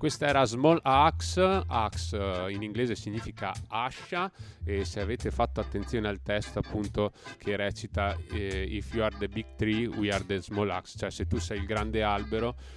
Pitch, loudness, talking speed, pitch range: 105 Hz, -30 LUFS, 185 wpm, 95-110 Hz